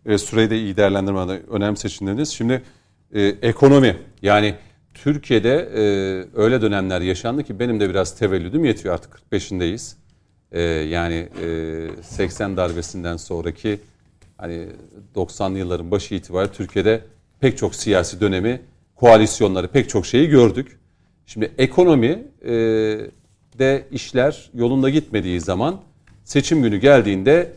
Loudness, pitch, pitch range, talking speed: -19 LUFS, 105 Hz, 95-120 Hz, 120 wpm